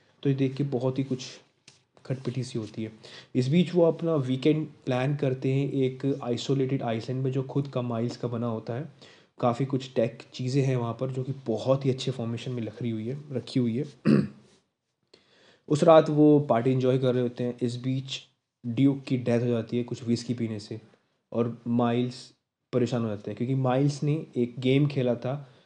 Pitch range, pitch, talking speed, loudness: 120-135 Hz, 130 Hz, 200 wpm, -27 LUFS